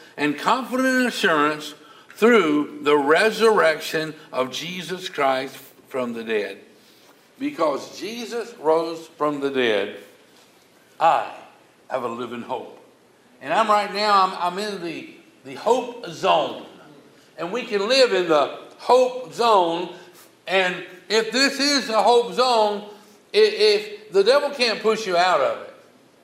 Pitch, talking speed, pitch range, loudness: 205 Hz, 135 wpm, 155-240 Hz, -21 LUFS